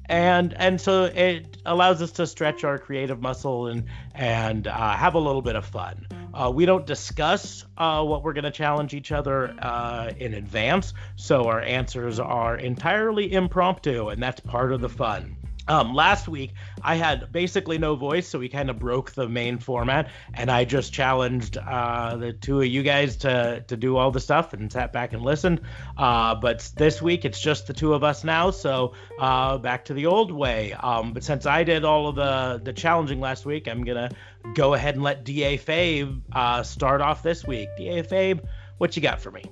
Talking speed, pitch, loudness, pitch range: 205 wpm, 130 Hz, -24 LUFS, 120-150 Hz